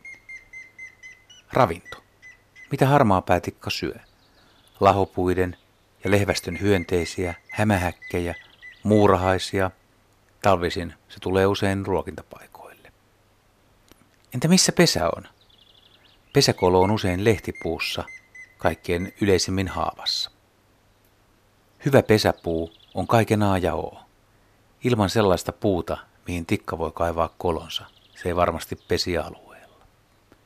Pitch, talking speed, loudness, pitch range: 100 Hz, 90 wpm, -23 LUFS, 95-110 Hz